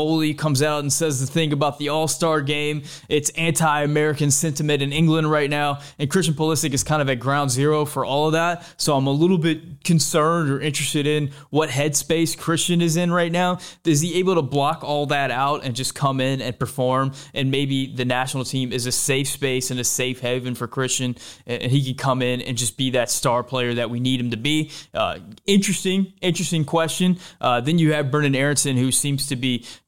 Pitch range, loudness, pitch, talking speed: 130-160 Hz, -21 LUFS, 145 Hz, 215 wpm